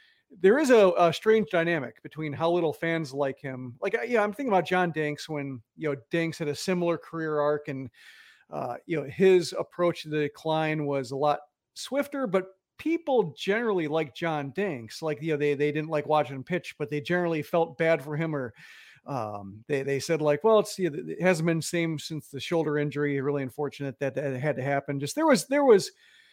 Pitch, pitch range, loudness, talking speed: 155 Hz, 145-180 Hz, -27 LUFS, 215 wpm